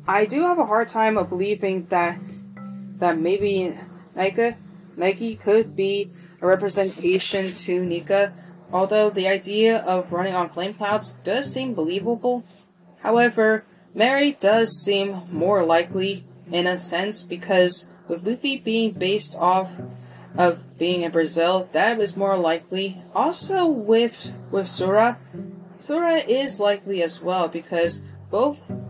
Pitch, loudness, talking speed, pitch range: 190 Hz, -21 LUFS, 135 wpm, 180-215 Hz